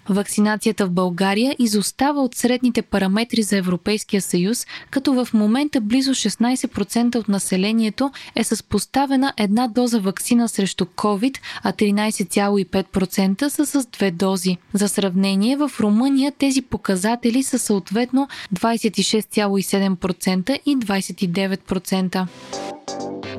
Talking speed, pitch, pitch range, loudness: 110 wpm, 215 Hz, 195-245 Hz, -20 LUFS